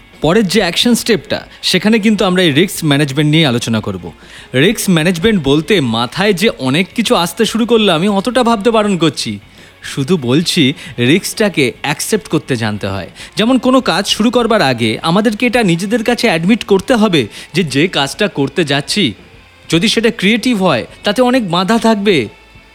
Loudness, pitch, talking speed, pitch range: -12 LUFS, 190 Hz, 160 wpm, 140-225 Hz